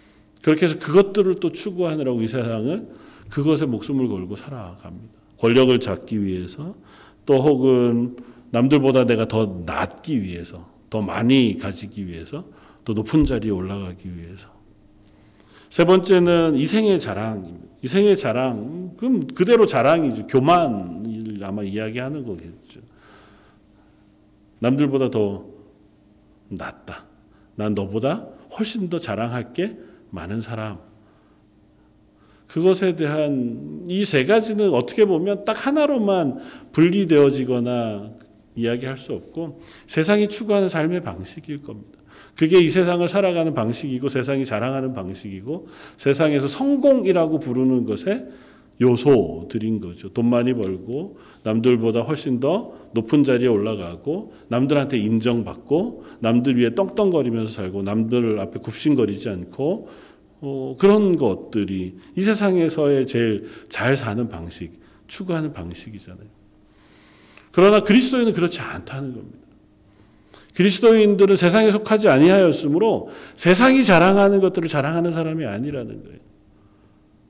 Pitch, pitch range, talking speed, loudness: 125 Hz, 105-165 Hz, 290 characters per minute, -20 LUFS